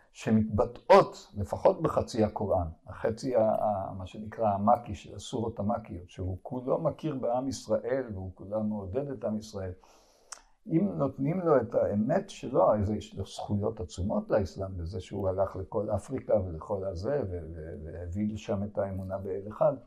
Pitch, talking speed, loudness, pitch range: 100 Hz, 145 wpm, -30 LUFS, 95-110 Hz